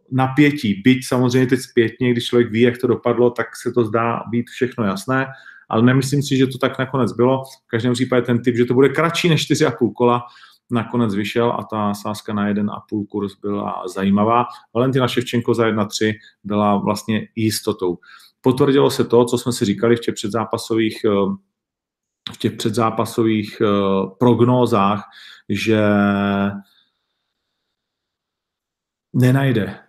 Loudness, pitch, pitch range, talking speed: -18 LUFS, 120 Hz, 105-125 Hz, 145 wpm